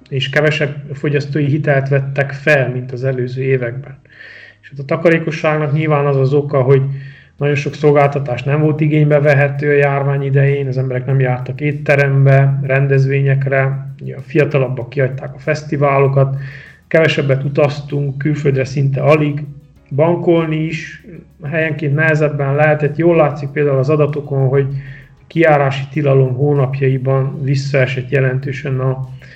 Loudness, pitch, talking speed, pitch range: -15 LUFS, 140 Hz, 125 wpm, 135-150 Hz